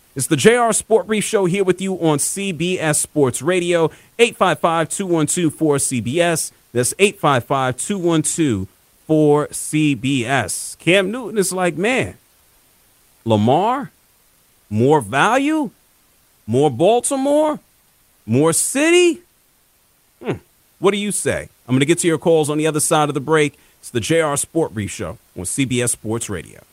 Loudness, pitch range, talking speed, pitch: -17 LUFS, 135-195 Hz, 135 wpm, 160 Hz